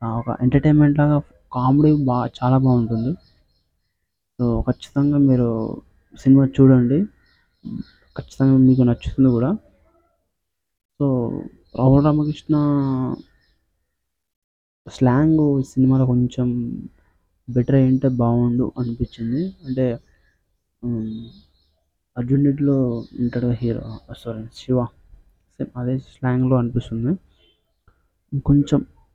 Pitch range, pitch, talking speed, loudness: 110-135 Hz, 125 Hz, 80 wpm, -19 LUFS